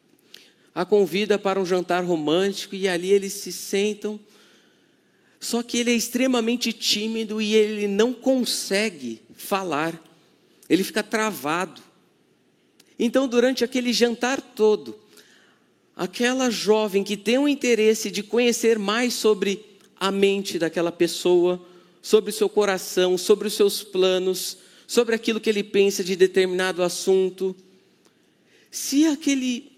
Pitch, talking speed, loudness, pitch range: 205 Hz, 125 wpm, -22 LUFS, 185-230 Hz